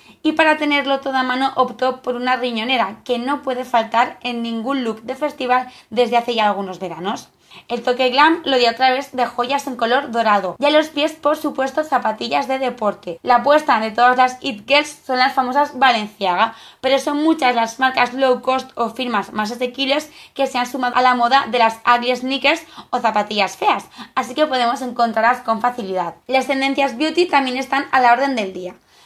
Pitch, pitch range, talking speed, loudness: 255 Hz, 235-275 Hz, 200 wpm, -18 LUFS